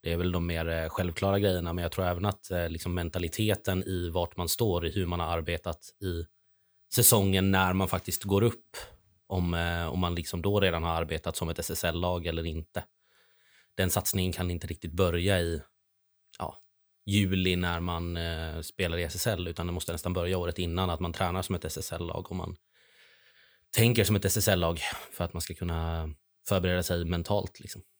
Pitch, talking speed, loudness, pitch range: 90 Hz, 180 wpm, -30 LUFS, 85-95 Hz